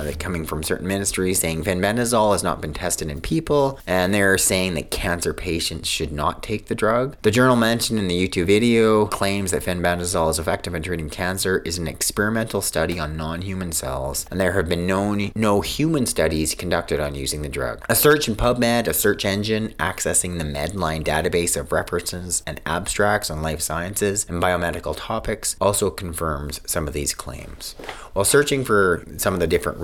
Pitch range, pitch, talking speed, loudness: 80-105 Hz, 90 Hz, 185 wpm, -21 LUFS